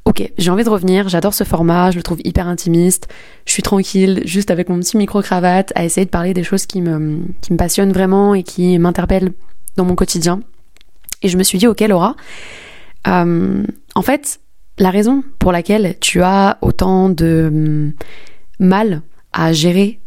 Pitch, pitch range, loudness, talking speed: 185 Hz, 175-200 Hz, -14 LUFS, 180 wpm